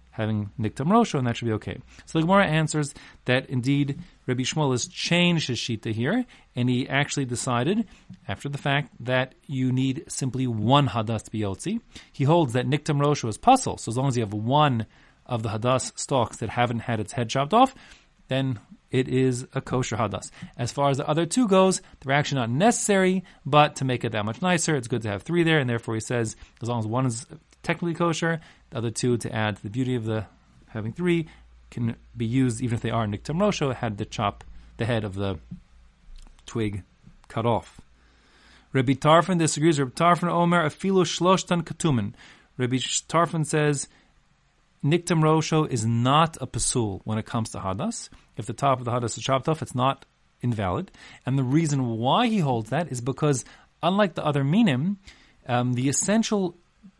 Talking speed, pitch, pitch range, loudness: 190 wpm, 130 Hz, 115-160 Hz, -25 LUFS